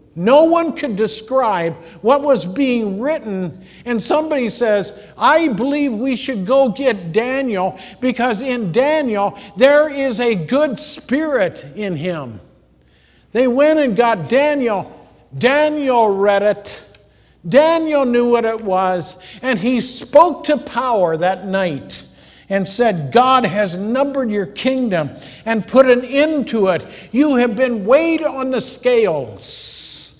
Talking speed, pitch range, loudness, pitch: 135 wpm, 200-275 Hz, -16 LUFS, 245 Hz